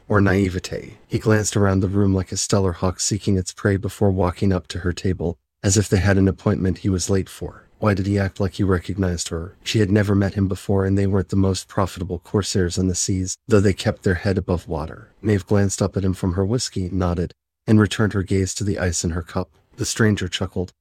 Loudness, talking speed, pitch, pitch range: -21 LUFS, 240 wpm, 95 Hz, 90-100 Hz